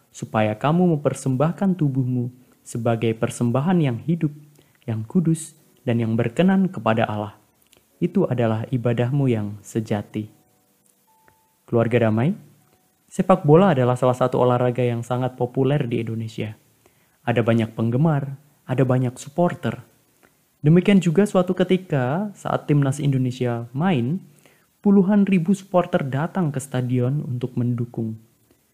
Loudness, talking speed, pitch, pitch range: -21 LUFS, 115 wpm, 130 Hz, 120-165 Hz